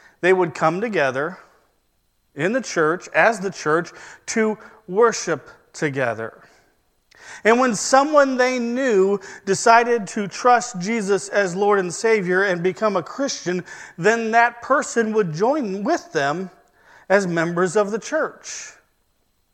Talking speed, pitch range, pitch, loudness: 130 wpm, 185-240 Hz, 215 Hz, -20 LUFS